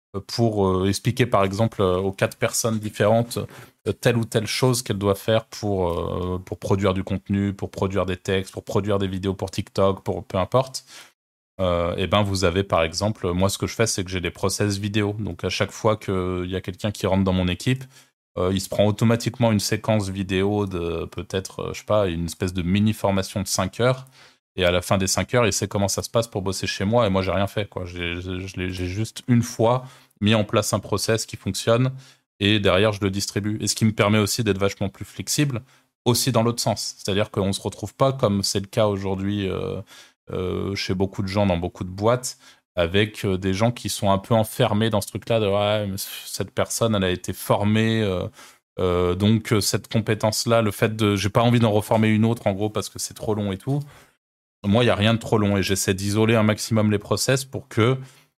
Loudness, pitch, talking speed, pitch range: -23 LUFS, 105 Hz, 235 wpm, 95-115 Hz